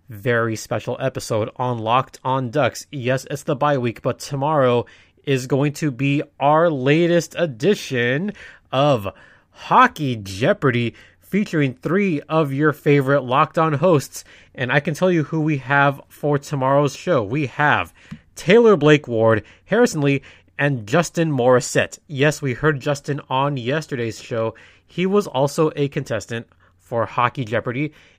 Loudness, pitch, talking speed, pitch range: -20 LUFS, 140 Hz, 145 wpm, 125-155 Hz